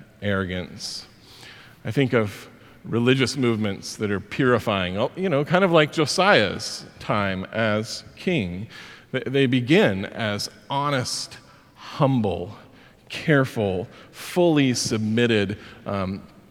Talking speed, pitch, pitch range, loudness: 100 wpm, 115 Hz, 105-135 Hz, -23 LUFS